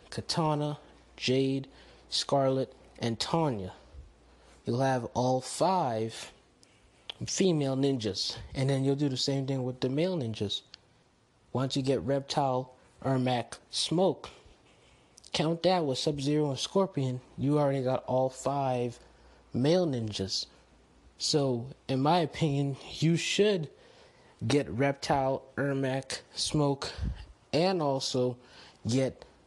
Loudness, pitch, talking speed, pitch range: -30 LUFS, 135 Hz, 110 wpm, 125-145 Hz